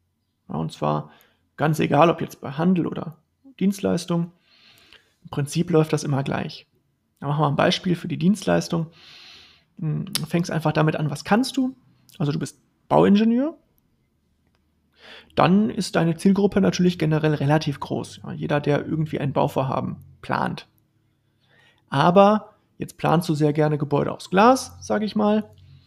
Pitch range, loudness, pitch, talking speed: 150-195 Hz, -22 LUFS, 160 Hz, 140 wpm